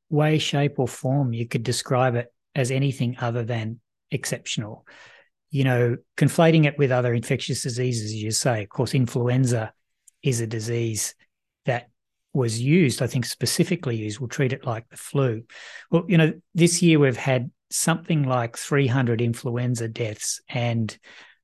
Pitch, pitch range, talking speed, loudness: 125 Hz, 120-140 Hz, 155 wpm, -23 LUFS